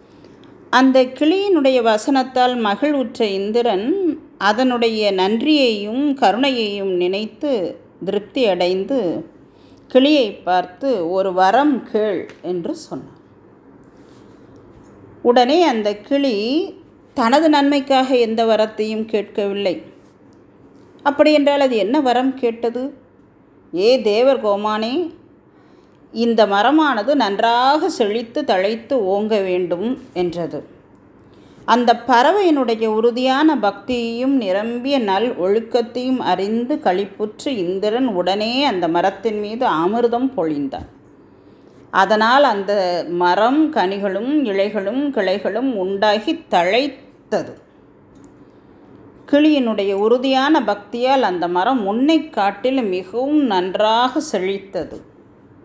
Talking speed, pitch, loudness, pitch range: 85 wpm, 235 Hz, -17 LUFS, 205-275 Hz